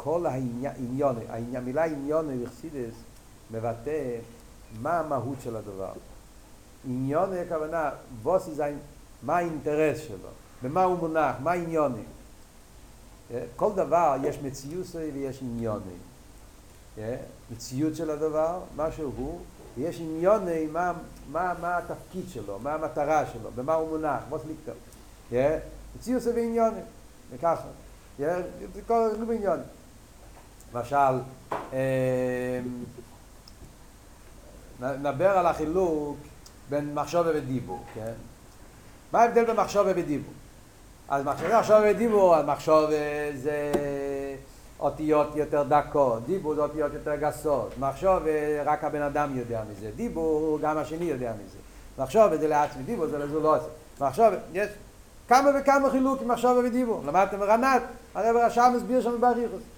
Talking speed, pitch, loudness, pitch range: 110 wpm, 150 Hz, -27 LUFS, 130-175 Hz